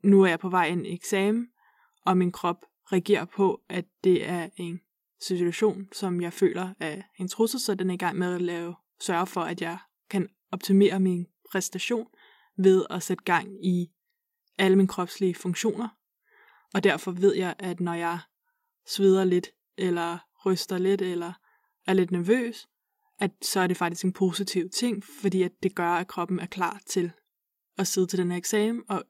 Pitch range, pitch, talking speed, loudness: 180-200 Hz, 185 Hz, 185 wpm, -27 LUFS